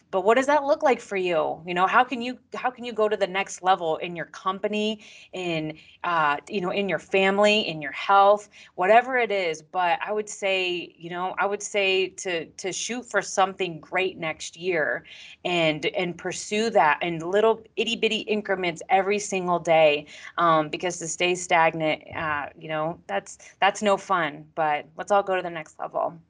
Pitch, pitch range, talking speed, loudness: 190 Hz, 165-210 Hz, 195 wpm, -24 LUFS